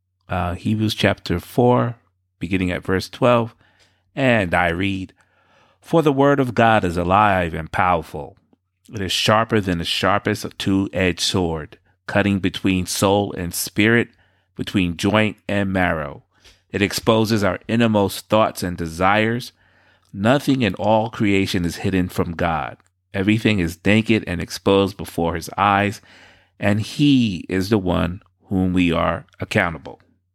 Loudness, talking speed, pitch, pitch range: -19 LUFS, 140 wpm, 95 Hz, 90-110 Hz